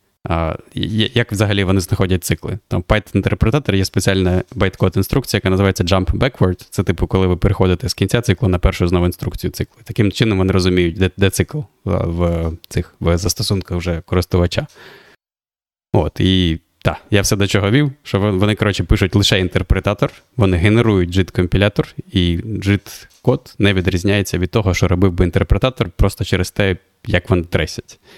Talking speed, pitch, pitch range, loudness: 165 wpm, 95 Hz, 90-110 Hz, -17 LUFS